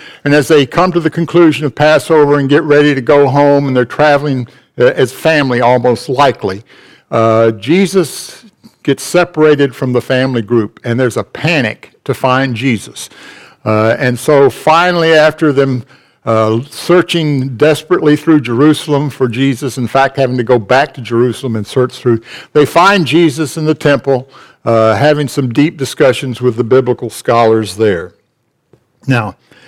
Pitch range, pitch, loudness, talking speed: 125-150 Hz, 135 Hz, -11 LUFS, 160 wpm